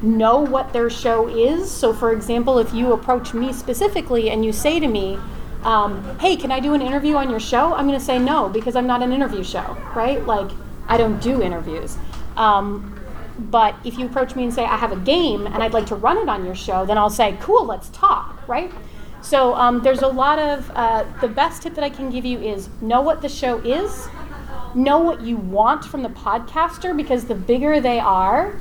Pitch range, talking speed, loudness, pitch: 225-275 Hz, 220 wpm, -19 LUFS, 245 Hz